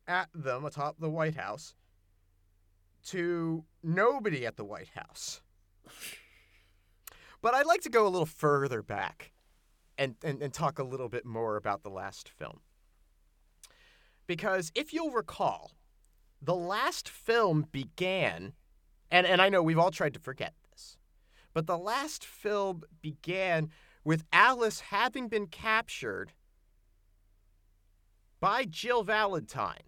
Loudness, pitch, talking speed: -31 LUFS, 145 Hz, 130 wpm